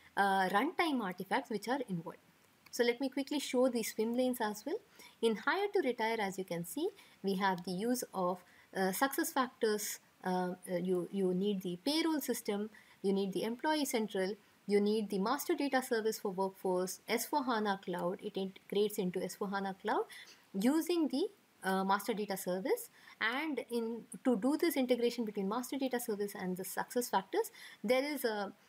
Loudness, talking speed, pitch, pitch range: -36 LUFS, 170 wpm, 220 Hz, 195-260 Hz